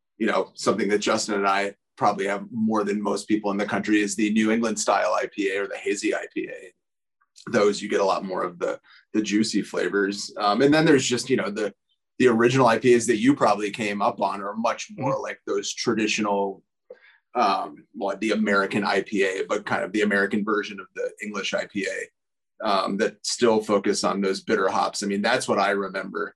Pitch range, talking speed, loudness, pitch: 100-120 Hz, 205 wpm, -24 LUFS, 105 Hz